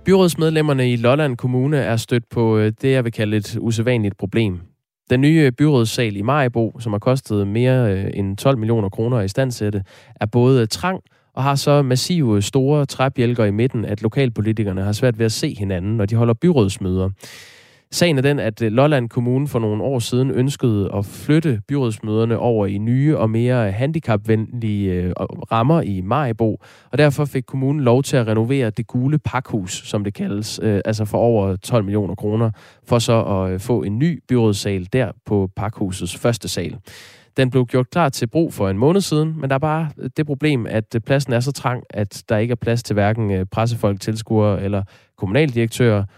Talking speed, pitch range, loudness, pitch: 180 wpm, 105-135 Hz, -19 LUFS, 115 Hz